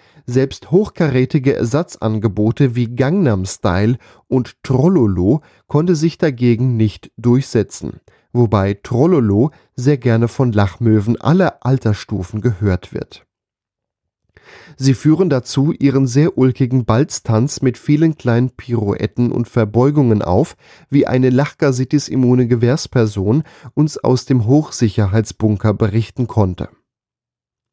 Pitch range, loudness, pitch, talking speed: 110-140 Hz, -16 LUFS, 125 Hz, 100 wpm